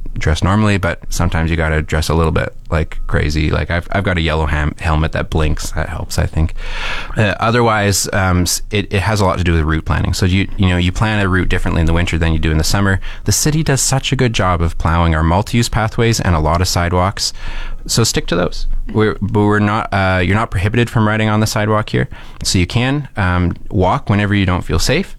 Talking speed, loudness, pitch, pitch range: 245 wpm, -15 LUFS, 95 Hz, 85-110 Hz